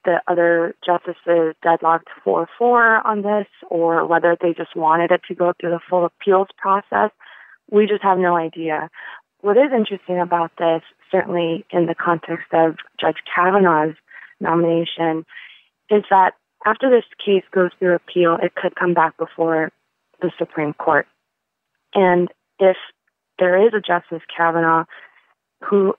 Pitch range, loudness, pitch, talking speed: 165-190 Hz, -18 LUFS, 175 Hz, 145 wpm